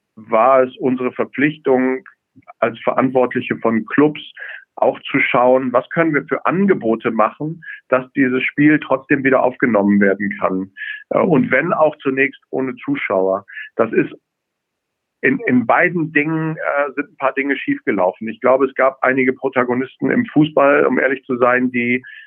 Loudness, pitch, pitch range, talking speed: -17 LUFS, 130 Hz, 125-150 Hz, 150 wpm